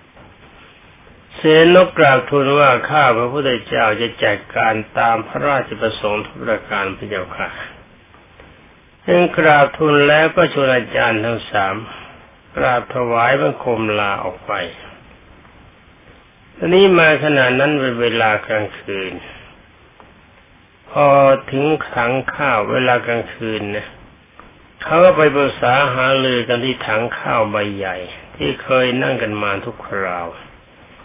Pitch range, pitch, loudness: 105-145 Hz, 120 Hz, -15 LUFS